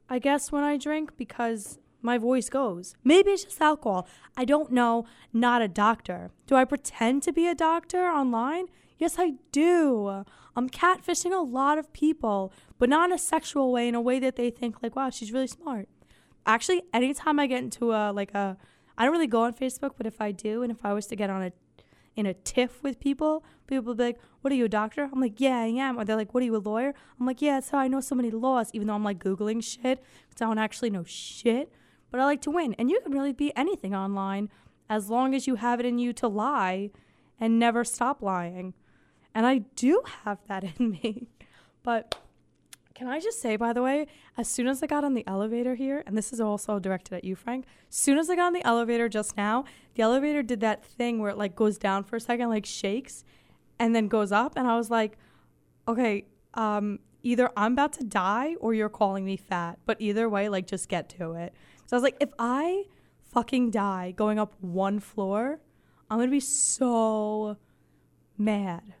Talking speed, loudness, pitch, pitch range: 225 wpm, -27 LUFS, 240 Hz, 210-270 Hz